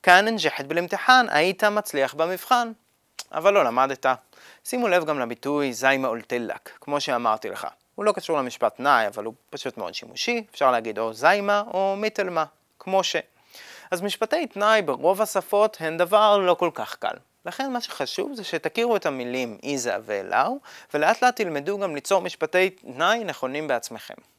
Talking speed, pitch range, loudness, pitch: 160 wpm, 145-210 Hz, -23 LUFS, 185 Hz